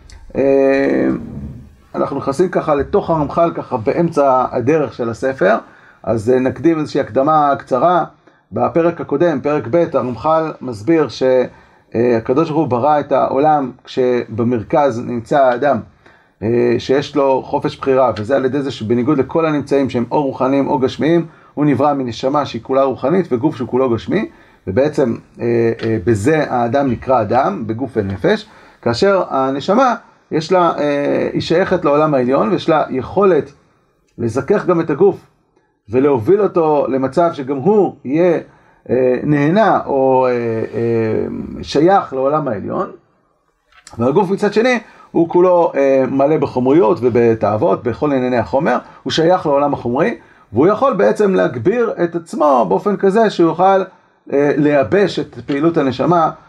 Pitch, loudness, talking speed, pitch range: 140 Hz, -15 LUFS, 140 wpm, 125-165 Hz